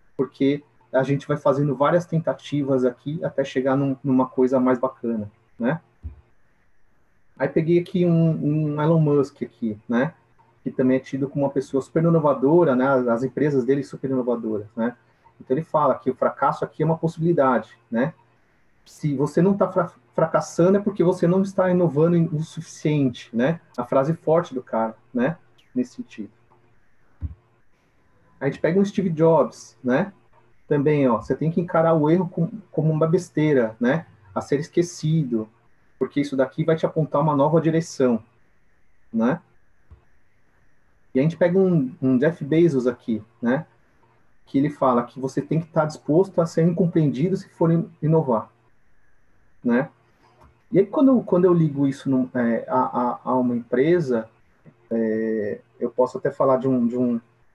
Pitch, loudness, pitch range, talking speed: 140 Hz, -22 LUFS, 125-165 Hz, 165 wpm